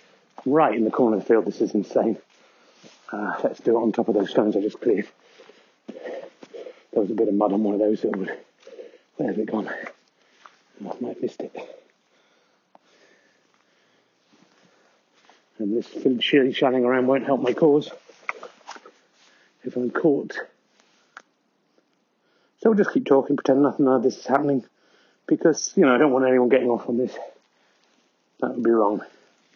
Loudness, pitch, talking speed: -22 LUFS, 135 Hz, 170 wpm